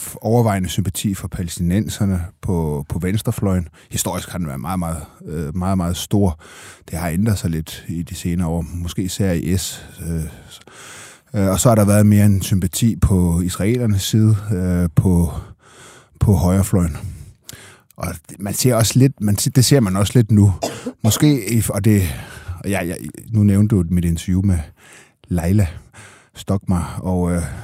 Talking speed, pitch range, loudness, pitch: 150 wpm, 85-105 Hz, -18 LUFS, 95 Hz